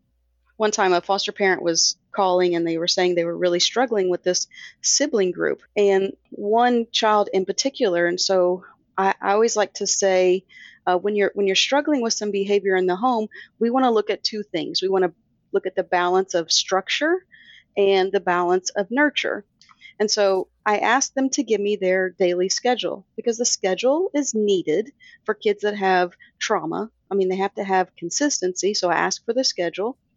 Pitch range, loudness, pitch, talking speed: 185-230 Hz, -21 LUFS, 195 Hz, 195 wpm